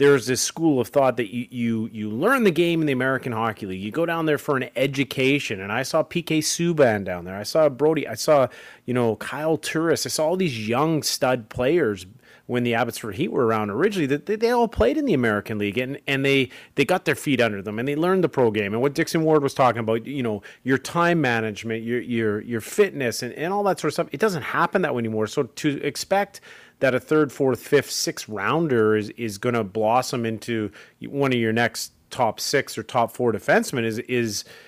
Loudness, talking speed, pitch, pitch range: -23 LUFS, 230 wpm, 130 Hz, 115-155 Hz